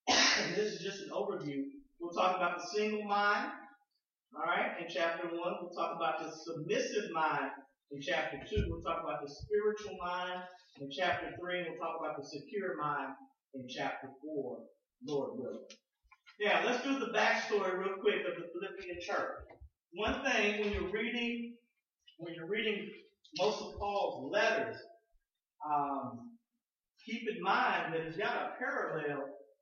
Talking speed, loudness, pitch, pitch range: 160 wpm, -36 LUFS, 185 Hz, 160-215 Hz